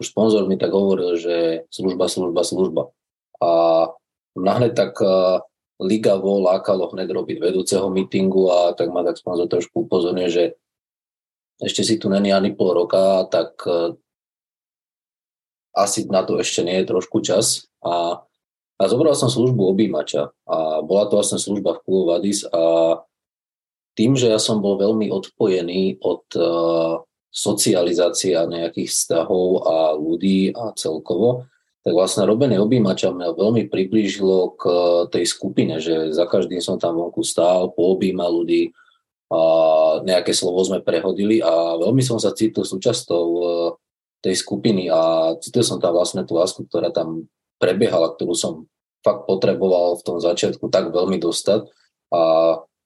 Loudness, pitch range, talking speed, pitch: -19 LUFS, 85-95 Hz, 145 wpm, 90 Hz